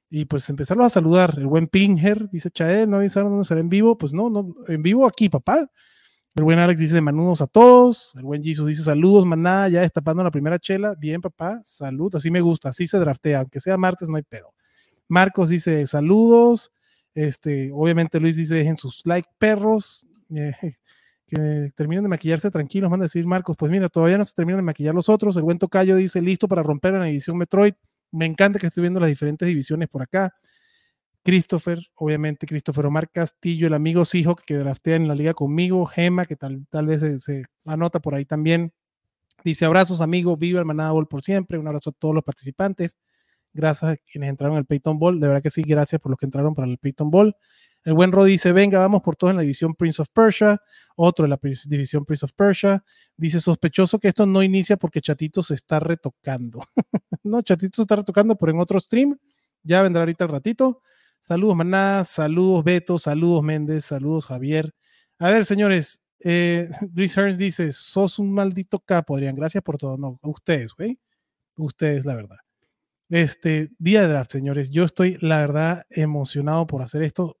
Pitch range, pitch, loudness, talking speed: 150-190 Hz, 170 Hz, -20 LUFS, 200 wpm